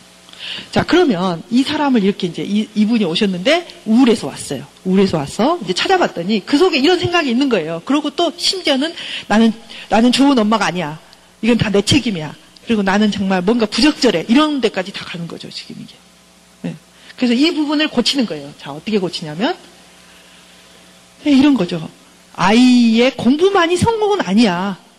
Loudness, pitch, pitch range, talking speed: -15 LUFS, 220 Hz, 170-275 Hz, 360 characters per minute